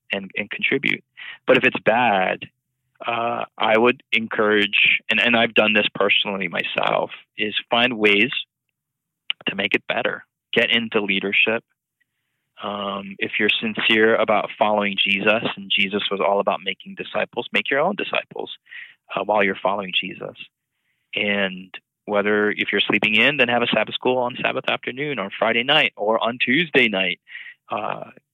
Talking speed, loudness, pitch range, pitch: 155 wpm, -20 LUFS, 100-120 Hz, 105 Hz